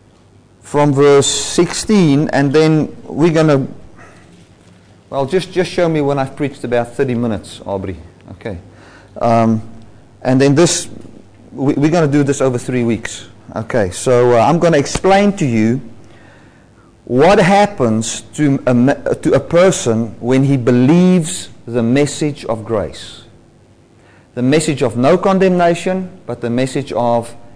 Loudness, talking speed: -14 LUFS, 145 wpm